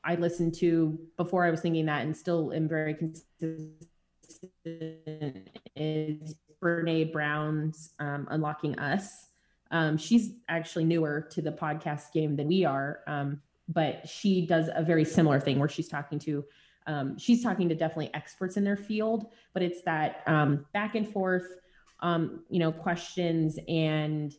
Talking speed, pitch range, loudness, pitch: 155 wpm, 150-175 Hz, -30 LUFS, 160 Hz